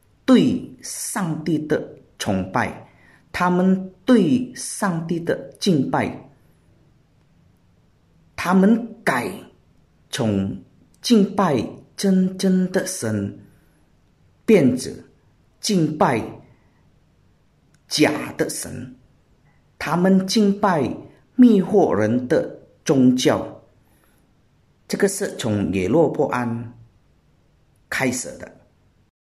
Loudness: -20 LUFS